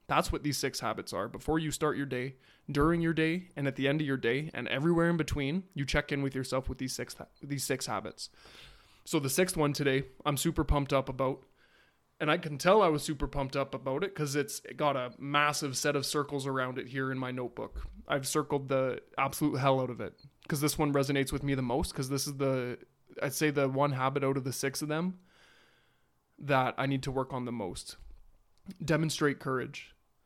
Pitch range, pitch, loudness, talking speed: 135-150 Hz, 140 Hz, -32 LUFS, 225 wpm